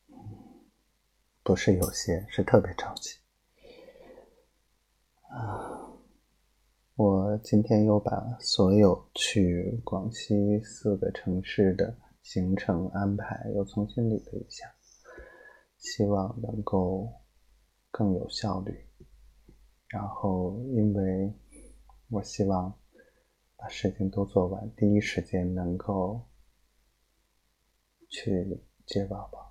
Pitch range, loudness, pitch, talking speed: 95-110 Hz, -29 LUFS, 100 Hz, 140 characters per minute